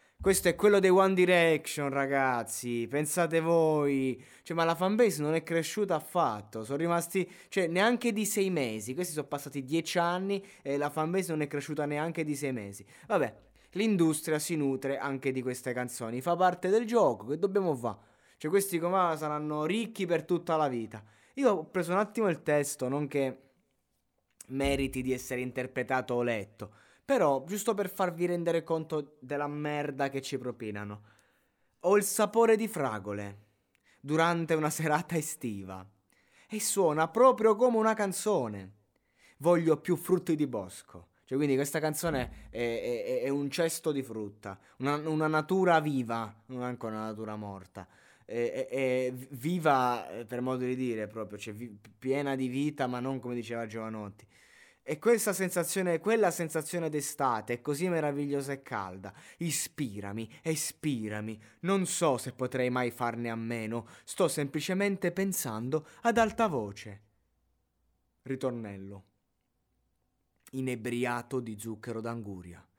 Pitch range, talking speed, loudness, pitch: 120-170 Hz, 150 wpm, -31 LUFS, 145 Hz